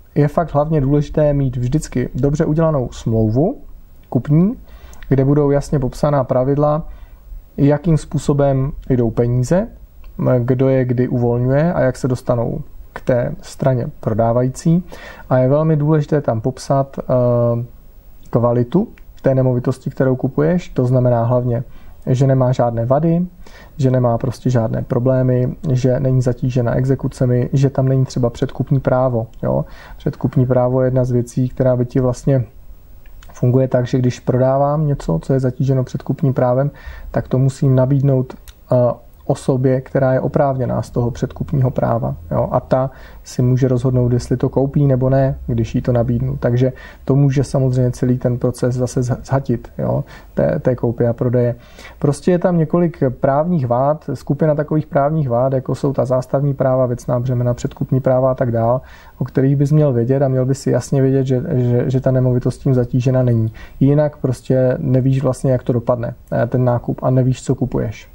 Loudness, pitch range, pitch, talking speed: -17 LUFS, 125-140 Hz, 130 Hz, 160 wpm